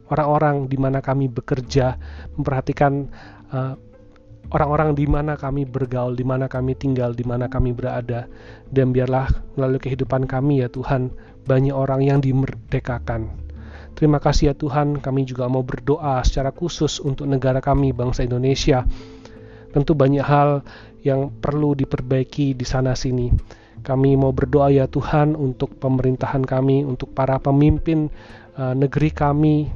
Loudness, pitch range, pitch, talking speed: -20 LUFS, 125-140 Hz, 135 Hz, 135 wpm